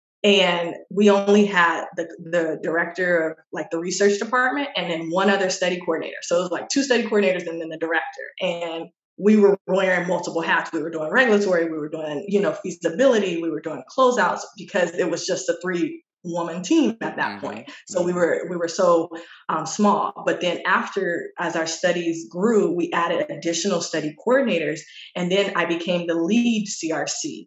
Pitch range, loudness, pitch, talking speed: 165-200 Hz, -22 LUFS, 180 Hz, 190 wpm